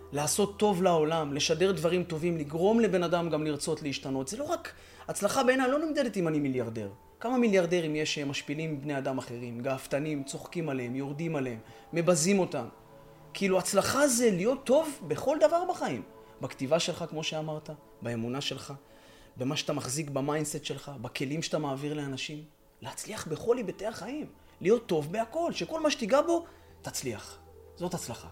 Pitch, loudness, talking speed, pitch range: 155 Hz, -30 LUFS, 155 wpm, 135-195 Hz